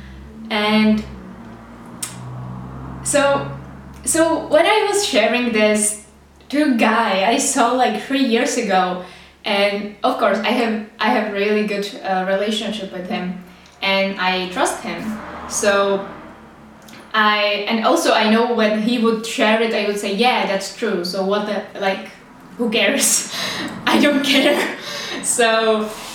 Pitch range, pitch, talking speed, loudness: 195-235 Hz, 215 Hz, 140 wpm, -18 LUFS